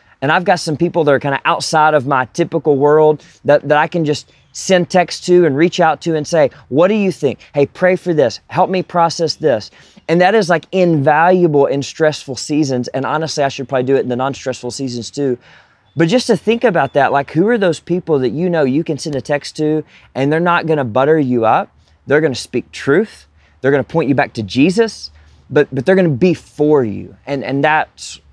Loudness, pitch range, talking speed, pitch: -15 LUFS, 135-170 Hz, 235 wpm, 150 Hz